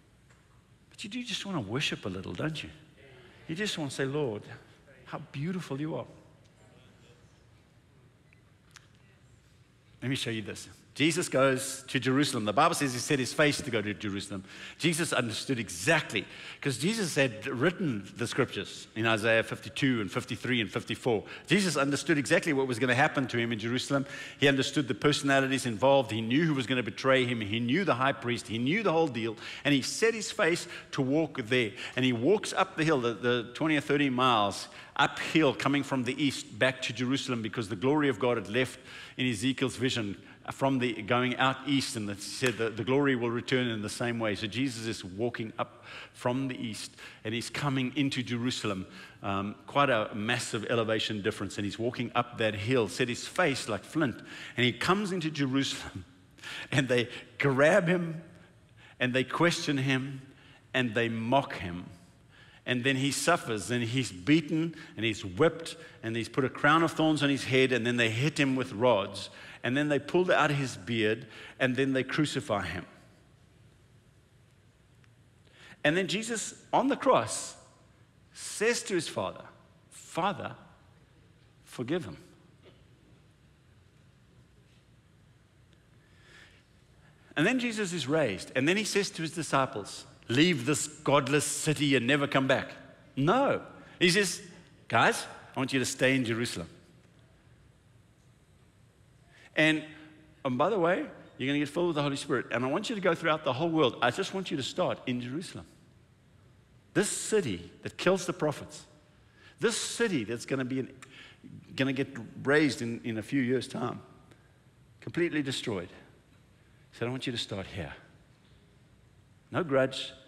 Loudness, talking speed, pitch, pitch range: -29 LUFS, 170 wpm, 130 Hz, 120-150 Hz